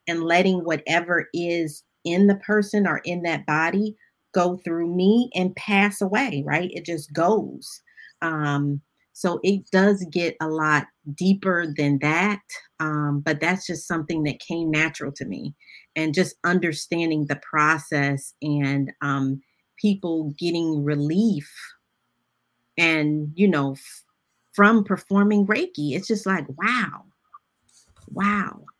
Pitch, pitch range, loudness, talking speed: 170 Hz, 150-195 Hz, -23 LUFS, 130 wpm